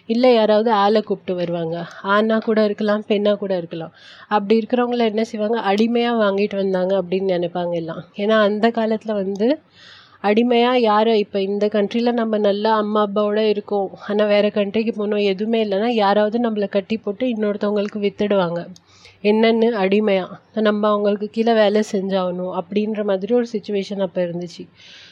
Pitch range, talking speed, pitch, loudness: 195-220 Hz, 145 wpm, 210 Hz, -19 LUFS